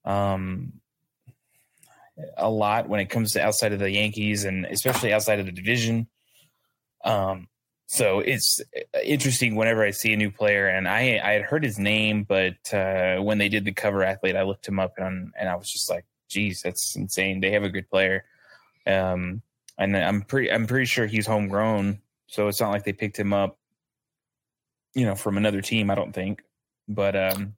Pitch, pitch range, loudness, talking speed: 105 Hz, 95-110 Hz, -24 LUFS, 190 wpm